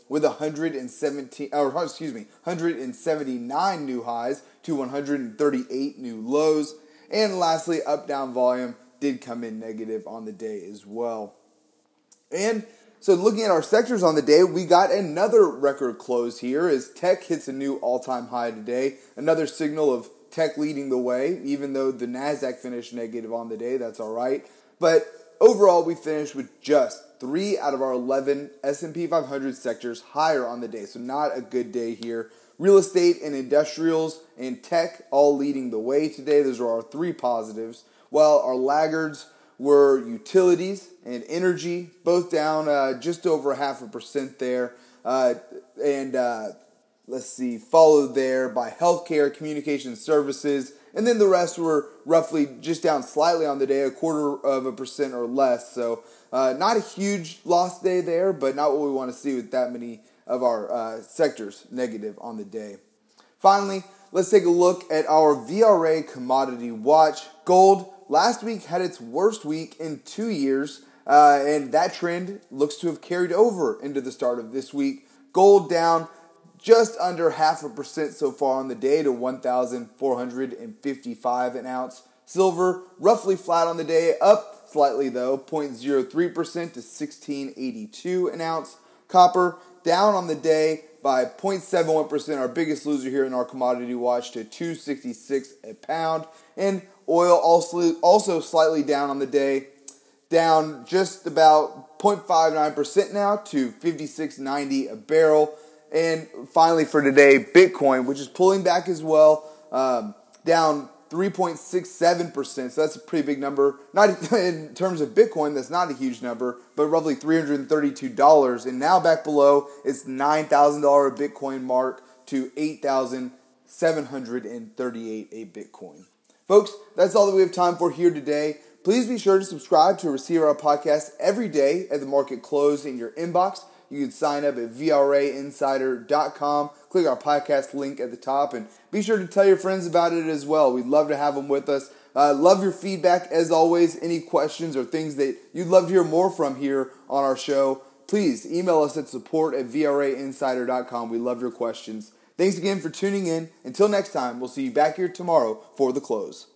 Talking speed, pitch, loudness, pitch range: 165 wpm, 150 Hz, -22 LUFS, 135-175 Hz